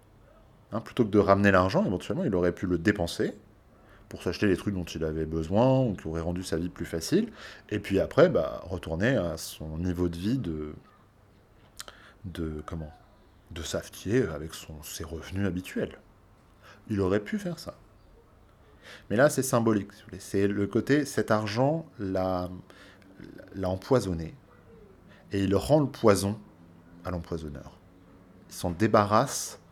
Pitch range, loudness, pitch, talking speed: 85-105 Hz, -28 LUFS, 95 Hz, 155 wpm